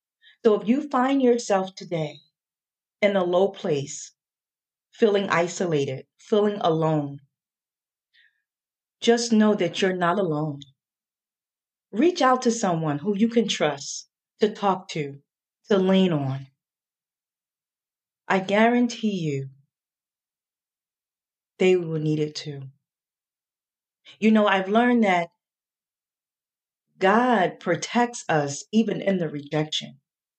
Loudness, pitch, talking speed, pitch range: -23 LUFS, 190 Hz, 105 wpm, 155-215 Hz